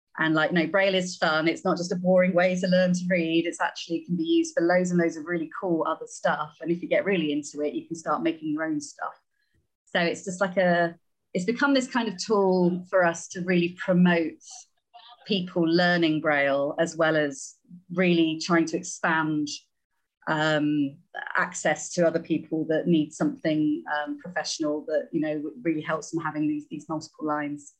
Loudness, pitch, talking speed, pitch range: -26 LUFS, 170 Hz, 200 wpm, 155-185 Hz